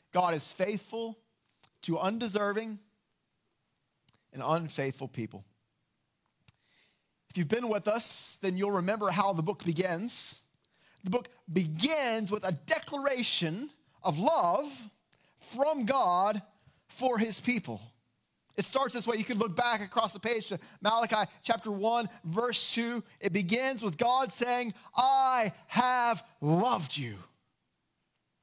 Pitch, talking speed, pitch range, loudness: 210 Hz, 125 wpm, 175-235 Hz, -30 LUFS